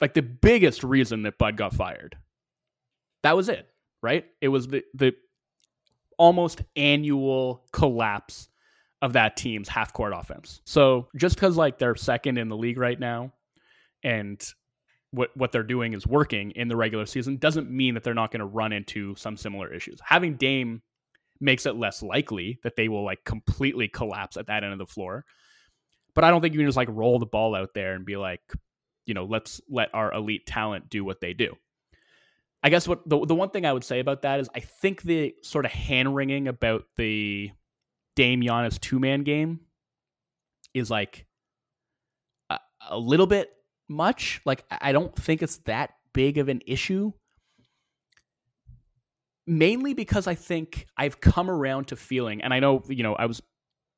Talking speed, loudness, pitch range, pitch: 180 wpm, -25 LUFS, 110-145 Hz, 125 Hz